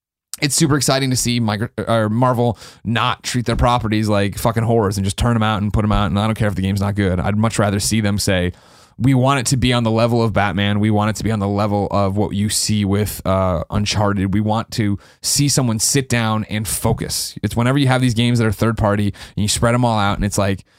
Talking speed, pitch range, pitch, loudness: 260 wpm, 100-120 Hz, 110 Hz, -17 LUFS